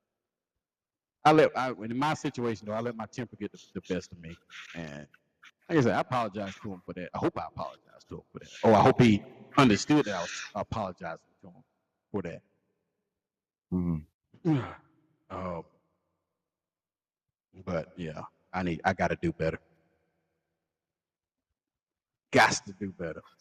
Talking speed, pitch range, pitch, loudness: 160 wpm, 85-120 Hz, 100 Hz, -29 LUFS